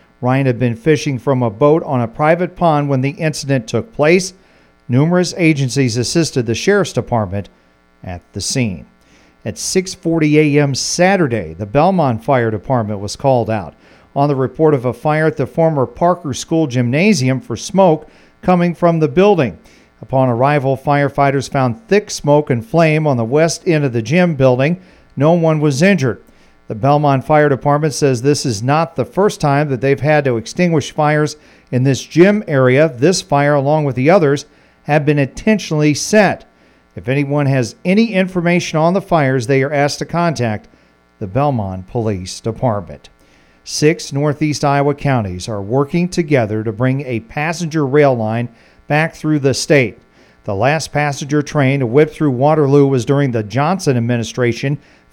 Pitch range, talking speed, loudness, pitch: 120-155 Hz, 165 wpm, -15 LUFS, 140 Hz